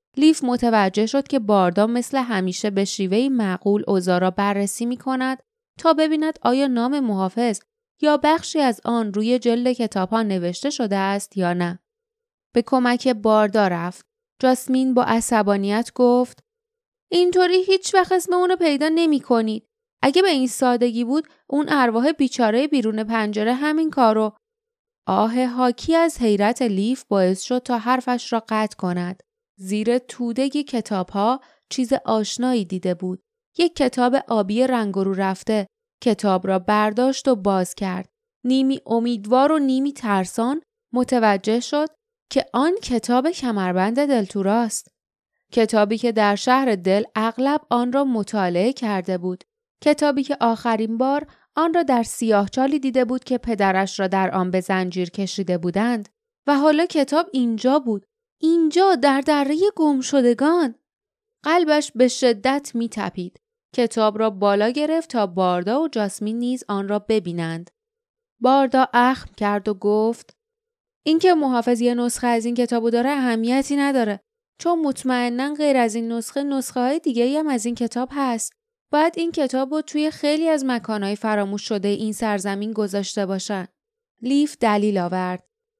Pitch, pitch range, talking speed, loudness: 245 Hz, 210-290 Hz, 145 wpm, -21 LUFS